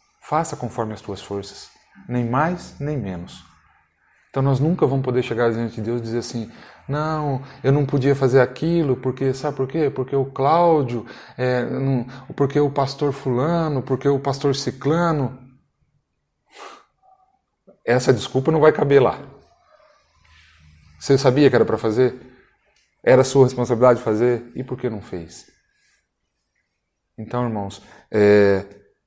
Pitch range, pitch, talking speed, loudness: 120-145 Hz, 130 Hz, 140 wpm, -20 LUFS